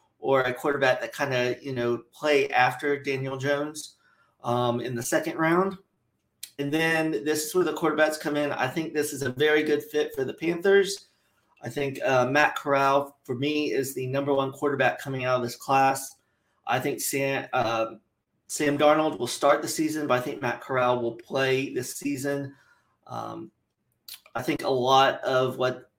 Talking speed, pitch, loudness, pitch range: 185 wpm, 140 Hz, -26 LUFS, 130-150 Hz